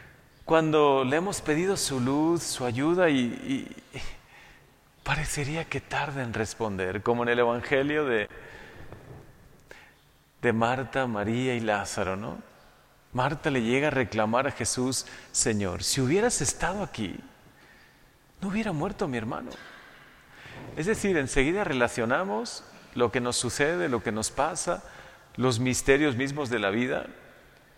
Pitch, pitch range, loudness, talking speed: 130 Hz, 120-150 Hz, -27 LUFS, 135 wpm